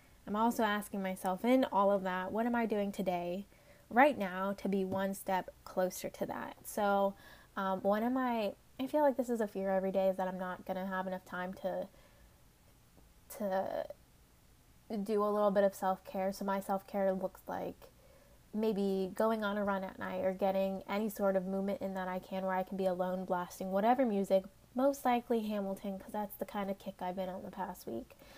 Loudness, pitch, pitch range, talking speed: -35 LUFS, 195 Hz, 190-210 Hz, 210 wpm